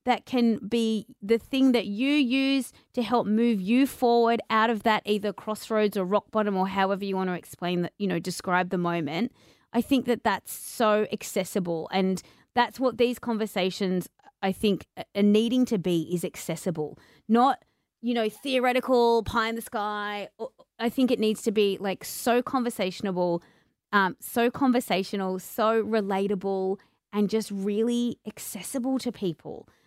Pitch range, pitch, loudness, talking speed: 195-240 Hz, 215 Hz, -26 LUFS, 160 wpm